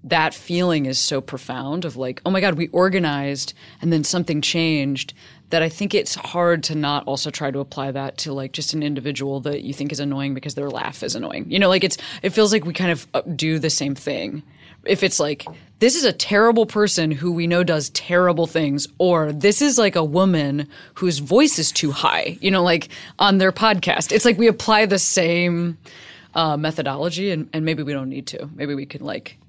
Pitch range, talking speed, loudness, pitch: 145-180 Hz, 220 wpm, -20 LUFS, 160 Hz